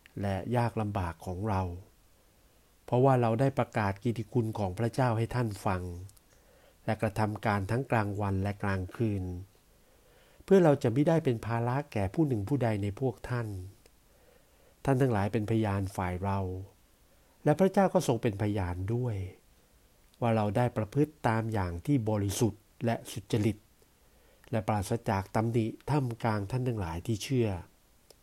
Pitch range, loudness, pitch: 100-120 Hz, -31 LUFS, 110 Hz